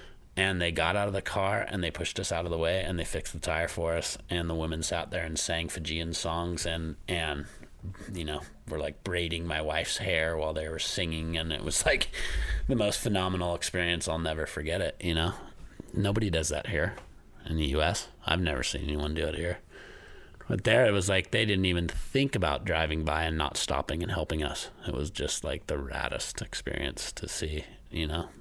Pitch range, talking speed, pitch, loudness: 80-90 Hz, 215 wpm, 85 Hz, -30 LUFS